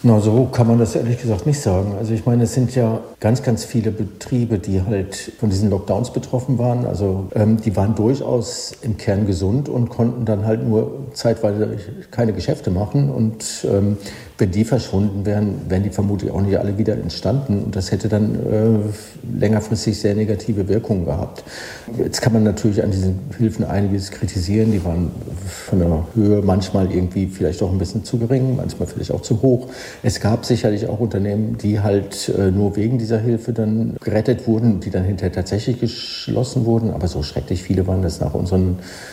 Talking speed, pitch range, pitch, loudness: 190 wpm, 100-115 Hz, 110 Hz, -19 LUFS